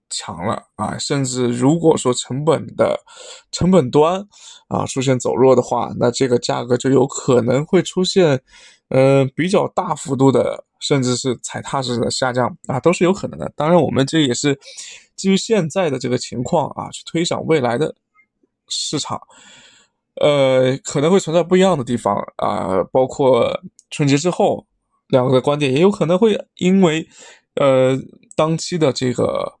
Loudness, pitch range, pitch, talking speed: -17 LUFS, 130-180 Hz, 145 Hz, 240 characters per minute